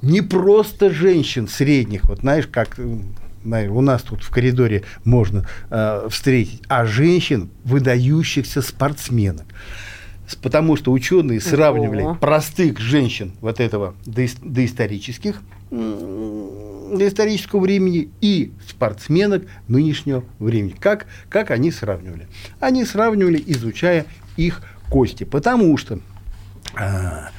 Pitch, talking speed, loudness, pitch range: 120 Hz, 105 wpm, -19 LUFS, 100-150 Hz